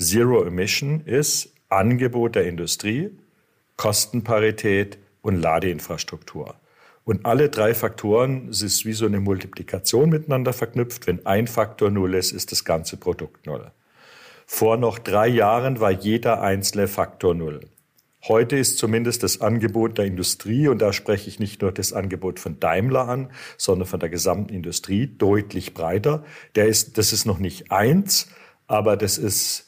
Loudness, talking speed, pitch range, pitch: -21 LUFS, 150 wpm, 95-120 Hz, 110 Hz